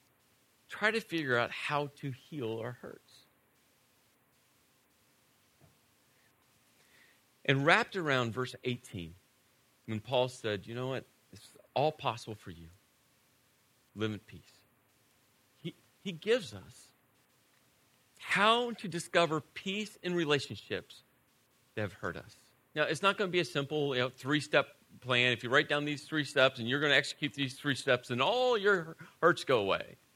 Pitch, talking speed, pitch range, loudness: 135 Hz, 150 wpm, 120-155 Hz, -32 LUFS